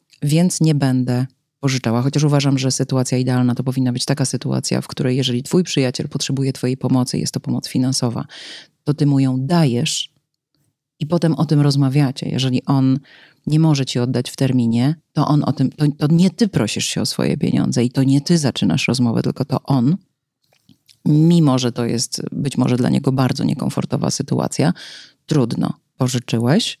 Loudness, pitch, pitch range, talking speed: -18 LUFS, 135 Hz, 130-150 Hz, 175 wpm